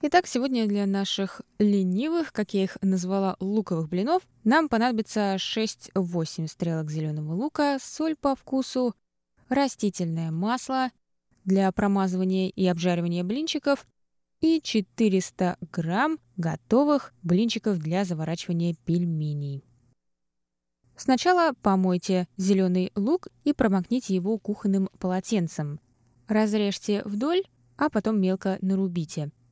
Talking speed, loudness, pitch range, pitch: 100 wpm, -26 LUFS, 175-235 Hz, 195 Hz